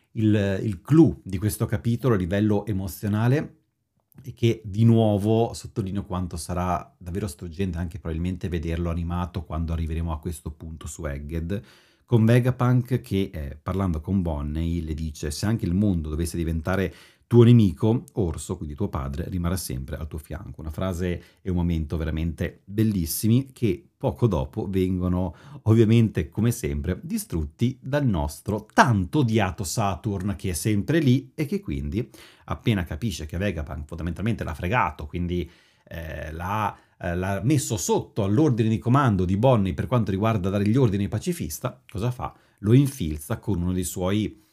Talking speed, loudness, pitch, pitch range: 155 wpm, -25 LUFS, 95 Hz, 85-115 Hz